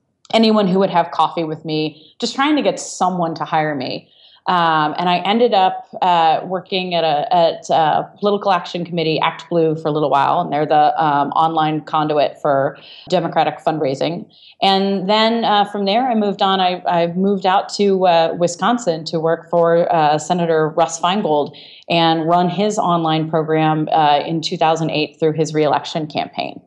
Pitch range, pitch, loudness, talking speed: 155-190 Hz, 170 Hz, -17 LUFS, 175 wpm